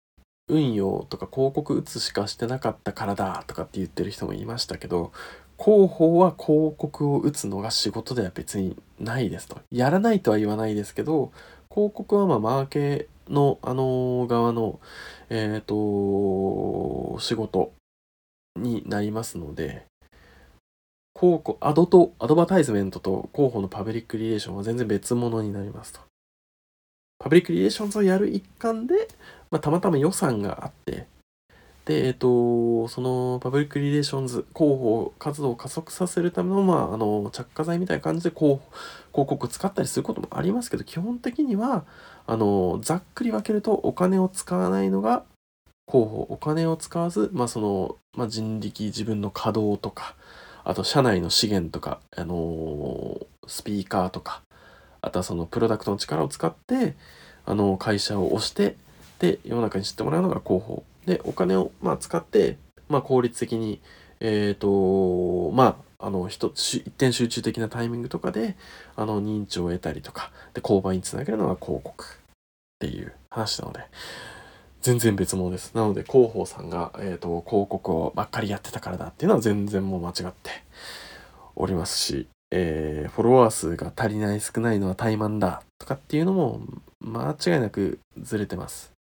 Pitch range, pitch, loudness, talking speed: 95-145 Hz, 110 Hz, -25 LUFS, 325 characters per minute